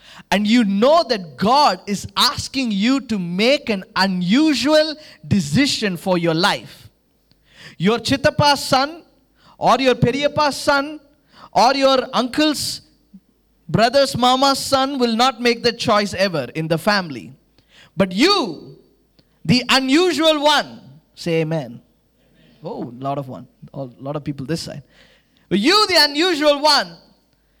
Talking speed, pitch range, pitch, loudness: 130 wpm, 185-285 Hz, 240 Hz, -17 LUFS